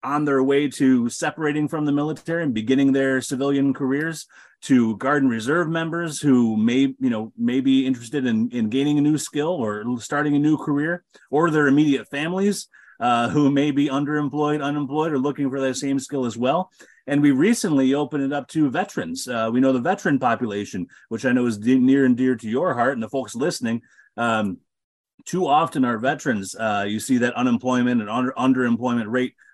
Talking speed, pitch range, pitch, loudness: 195 wpm, 125-150 Hz, 135 Hz, -21 LUFS